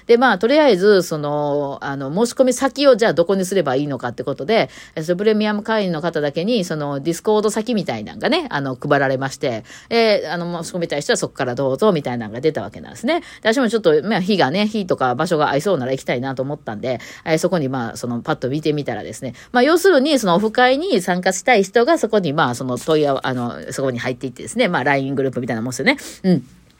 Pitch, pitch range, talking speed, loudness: 170 Hz, 135-220 Hz, 505 characters per minute, -18 LUFS